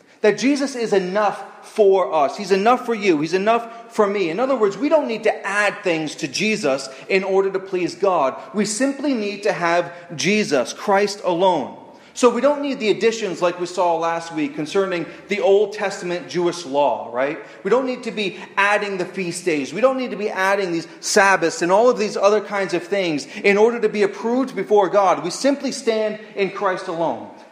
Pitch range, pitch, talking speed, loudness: 185-230 Hz, 205 Hz, 205 wpm, -20 LUFS